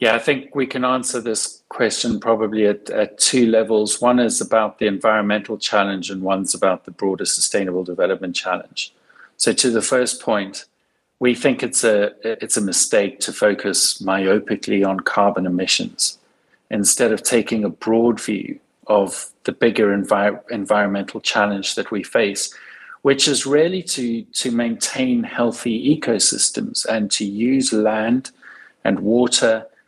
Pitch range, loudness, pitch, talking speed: 105-125 Hz, -19 LUFS, 110 Hz, 150 wpm